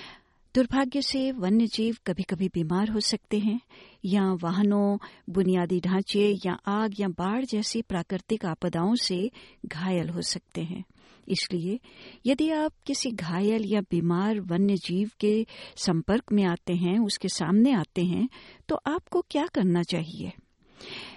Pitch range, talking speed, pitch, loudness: 185-230 Hz, 140 wpm, 200 Hz, -27 LUFS